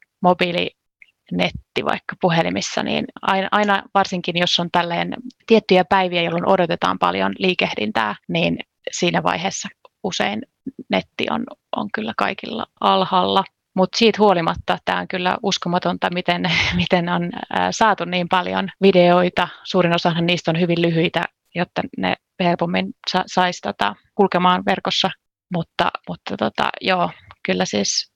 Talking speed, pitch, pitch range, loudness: 130 wpm, 180 Hz, 175-195 Hz, -19 LUFS